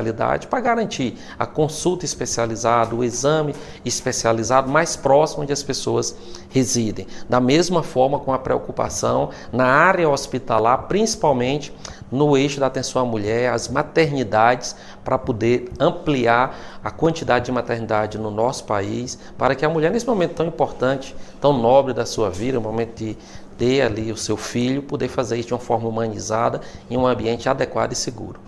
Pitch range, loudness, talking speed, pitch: 115-145 Hz, -20 LUFS, 160 wpm, 125 Hz